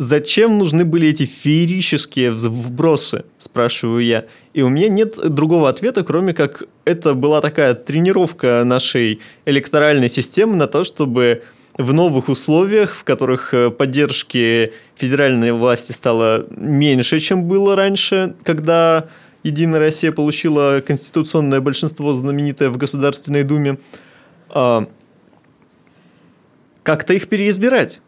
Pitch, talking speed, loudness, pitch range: 145 Hz, 110 wpm, -16 LUFS, 130-165 Hz